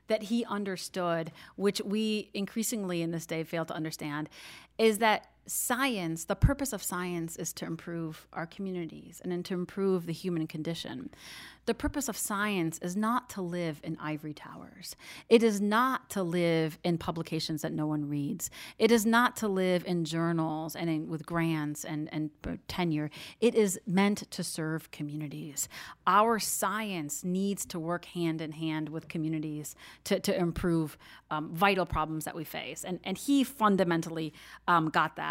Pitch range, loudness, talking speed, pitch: 160-200 Hz, -31 LUFS, 165 wpm, 175 Hz